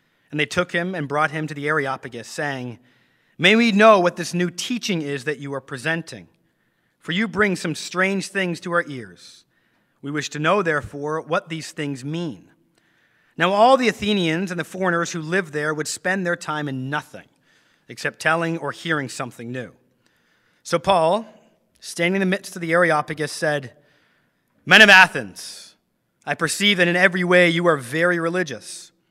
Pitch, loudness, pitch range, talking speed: 165 Hz, -20 LUFS, 145-185 Hz, 175 wpm